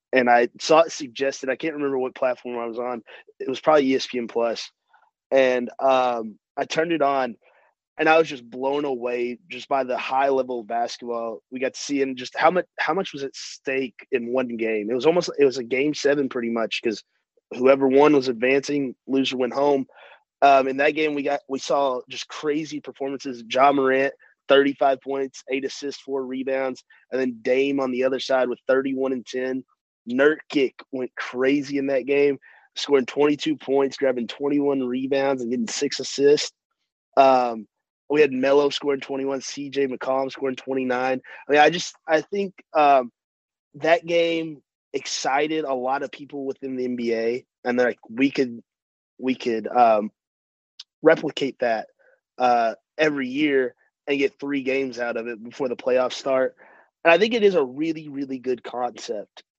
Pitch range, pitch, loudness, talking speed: 125-145 Hz, 135 Hz, -23 LUFS, 180 wpm